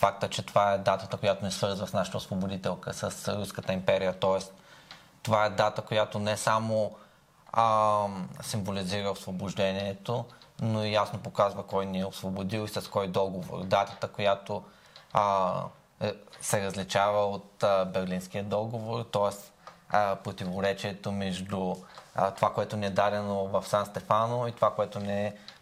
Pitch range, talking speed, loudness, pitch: 95-110 Hz, 145 wpm, -30 LUFS, 100 Hz